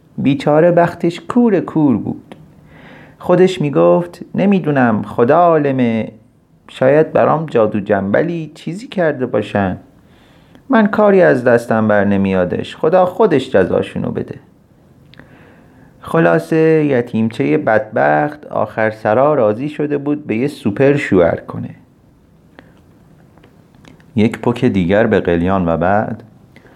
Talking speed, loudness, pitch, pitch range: 105 wpm, -14 LUFS, 135 Hz, 105-165 Hz